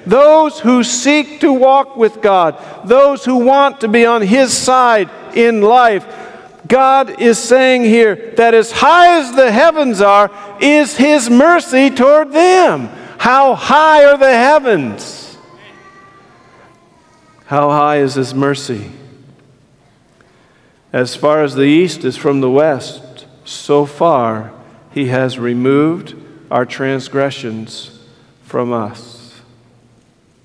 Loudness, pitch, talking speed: -11 LUFS, 205 Hz, 120 wpm